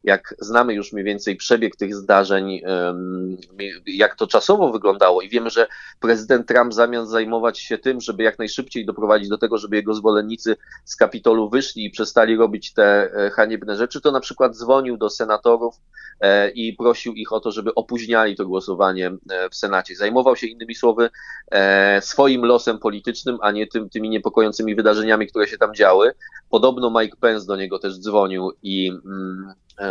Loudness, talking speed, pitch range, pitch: -19 LUFS, 160 wpm, 100-120 Hz, 110 Hz